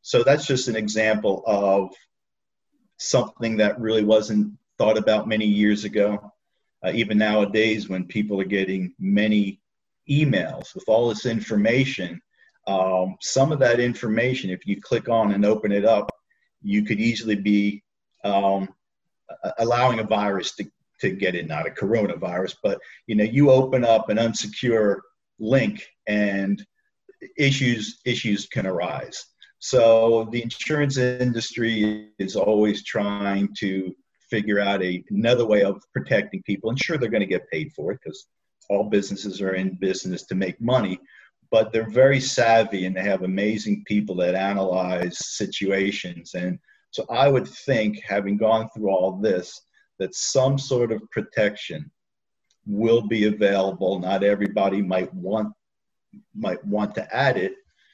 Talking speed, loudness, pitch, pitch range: 150 wpm, -22 LUFS, 105 Hz, 100-115 Hz